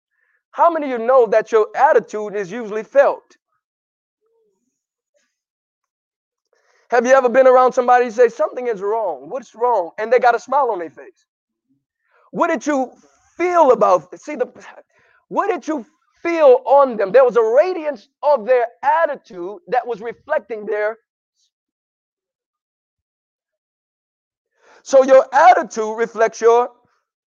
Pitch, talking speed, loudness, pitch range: 265 Hz, 135 wpm, -16 LUFS, 235-335 Hz